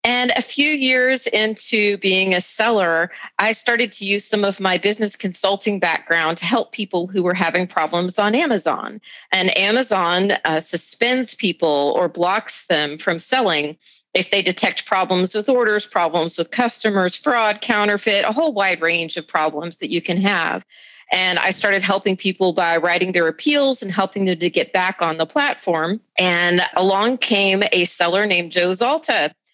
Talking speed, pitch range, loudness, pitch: 170 wpm, 175-215 Hz, -18 LUFS, 195 Hz